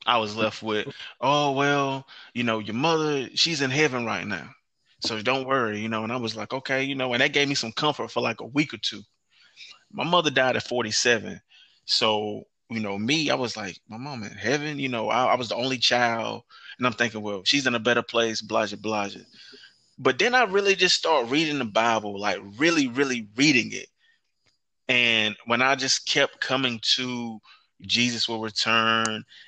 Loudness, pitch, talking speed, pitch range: -24 LUFS, 120 Hz, 200 wpm, 110-140 Hz